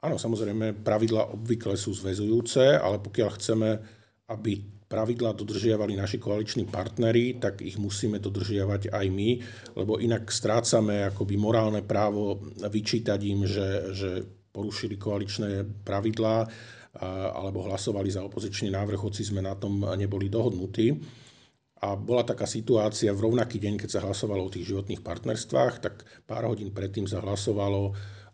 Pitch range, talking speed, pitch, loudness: 100-110 Hz, 140 wpm, 105 Hz, -28 LUFS